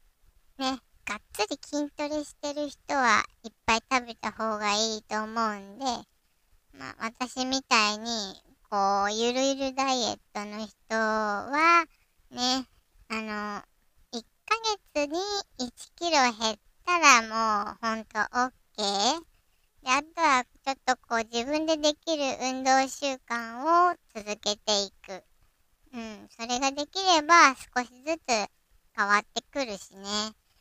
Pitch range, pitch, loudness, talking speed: 215-285 Hz, 245 Hz, -27 LUFS, 225 characters per minute